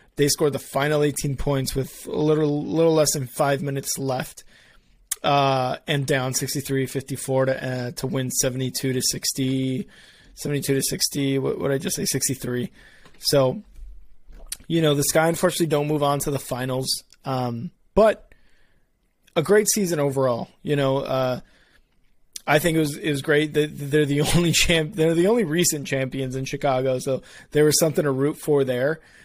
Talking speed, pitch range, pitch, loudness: 165 wpm, 130-150 Hz, 140 Hz, -22 LUFS